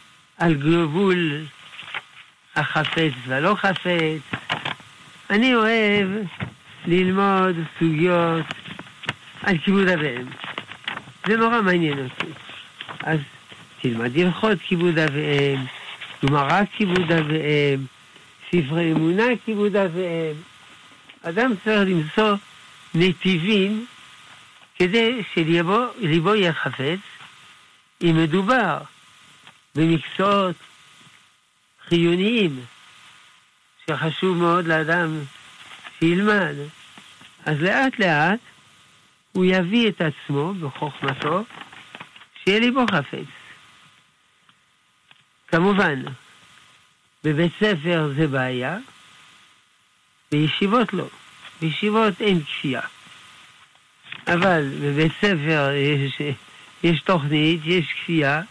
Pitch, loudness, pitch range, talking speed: 165 Hz, -21 LUFS, 140-190 Hz, 75 wpm